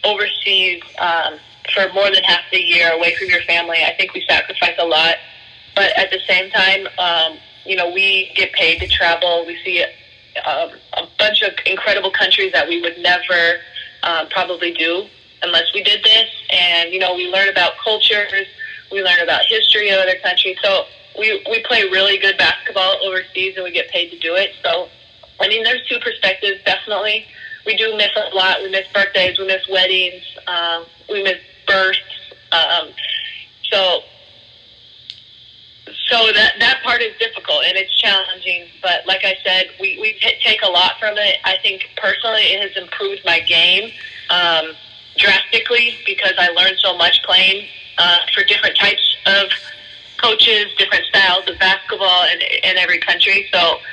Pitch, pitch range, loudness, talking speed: 190 Hz, 175-215 Hz, -14 LUFS, 170 wpm